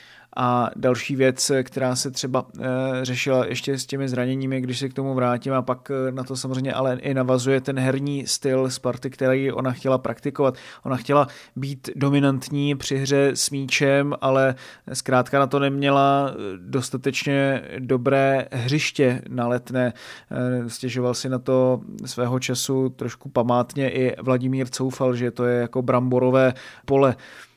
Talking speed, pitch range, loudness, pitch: 145 wpm, 125-135 Hz, -22 LUFS, 130 Hz